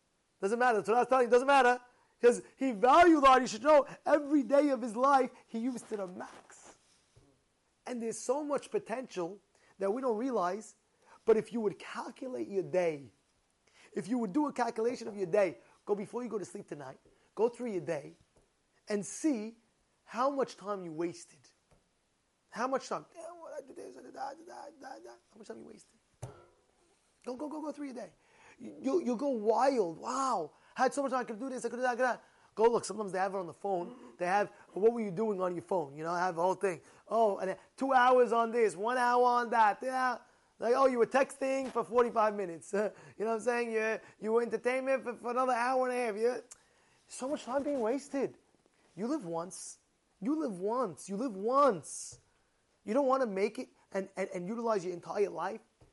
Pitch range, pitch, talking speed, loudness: 205-260 Hz, 235 Hz, 210 wpm, -32 LUFS